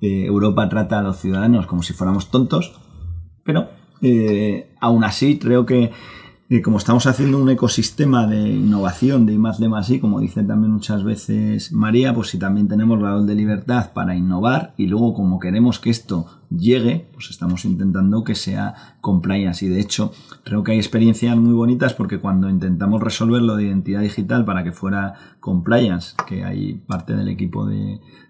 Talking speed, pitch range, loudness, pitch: 175 wpm, 95-120 Hz, -18 LUFS, 105 Hz